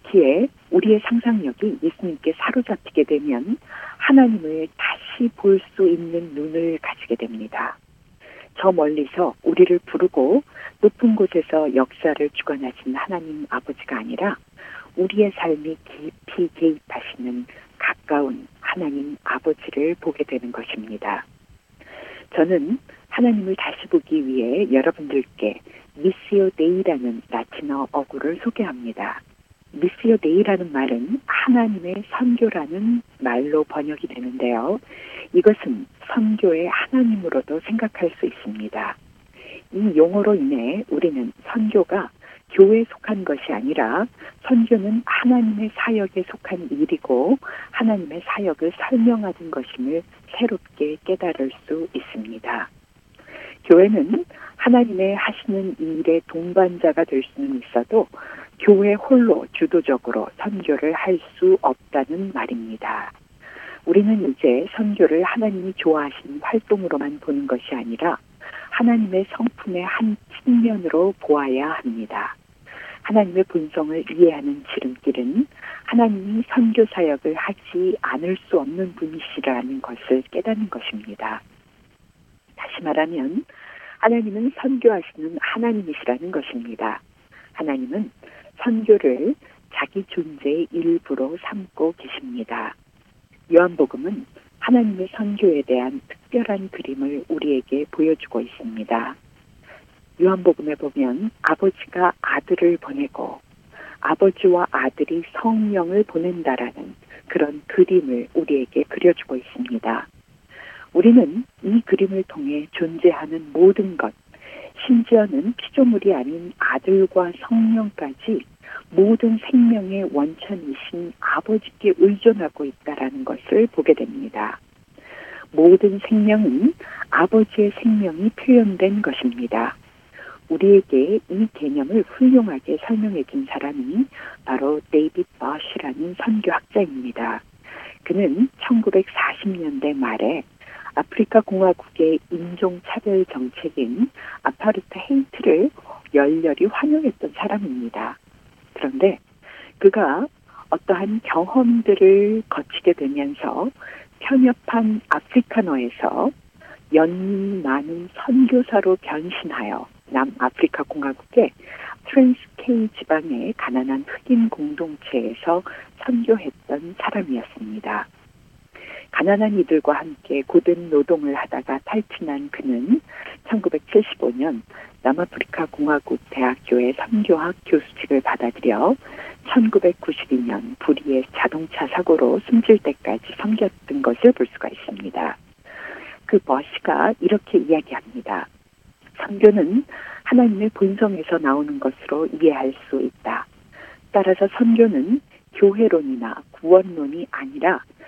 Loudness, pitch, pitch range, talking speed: -20 LUFS, 195 Hz, 160-240 Hz, 260 characters per minute